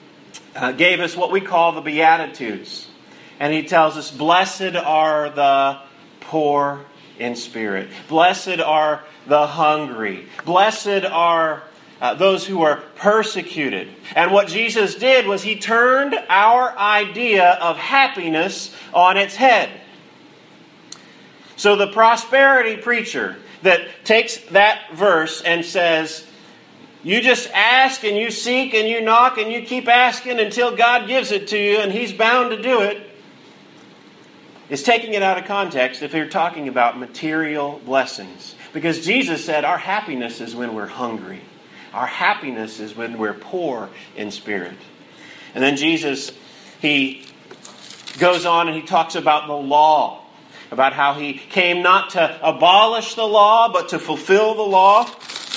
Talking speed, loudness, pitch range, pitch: 140 wpm, -17 LUFS, 150-215 Hz, 175 Hz